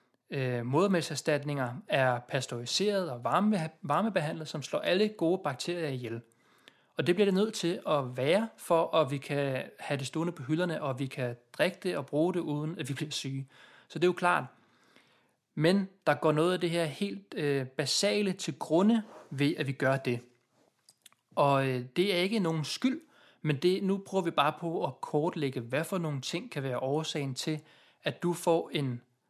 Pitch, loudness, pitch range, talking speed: 155 Hz, -31 LUFS, 140-180 Hz, 180 wpm